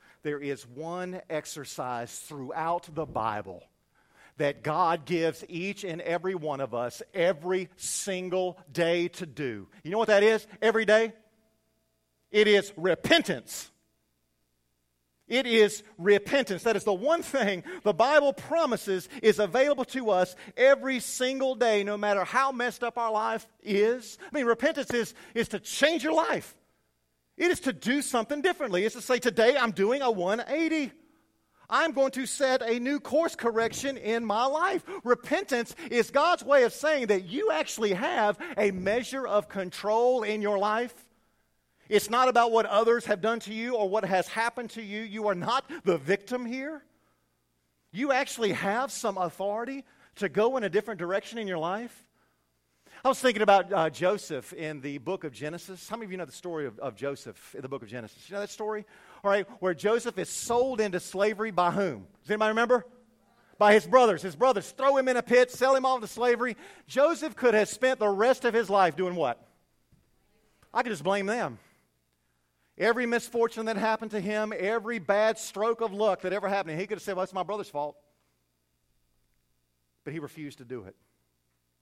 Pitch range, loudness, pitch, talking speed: 175-240 Hz, -27 LUFS, 210 Hz, 185 wpm